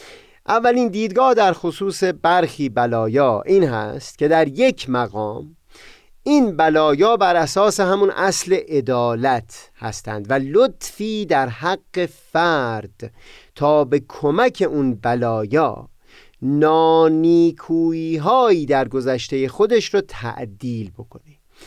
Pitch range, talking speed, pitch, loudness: 125-195 Hz, 100 wpm, 160 Hz, -18 LUFS